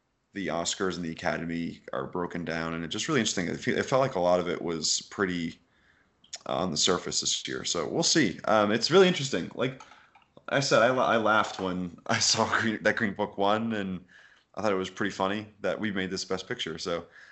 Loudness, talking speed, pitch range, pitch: -28 LUFS, 215 wpm, 85-110 Hz, 95 Hz